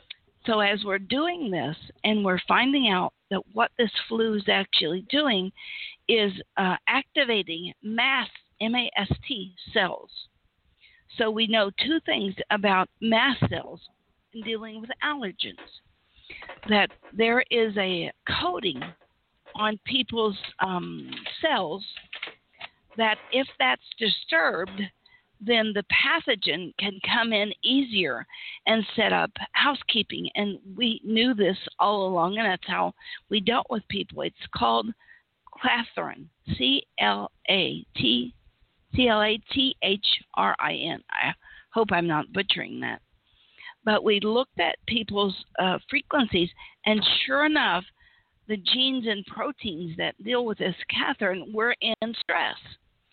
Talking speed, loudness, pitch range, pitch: 130 wpm, -25 LUFS, 195-245 Hz, 215 Hz